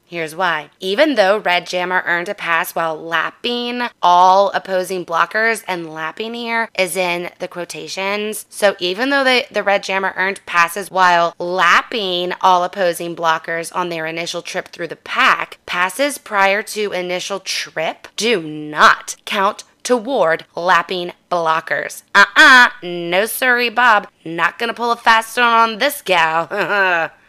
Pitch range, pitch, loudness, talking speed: 170-215 Hz, 185 Hz, -16 LUFS, 150 wpm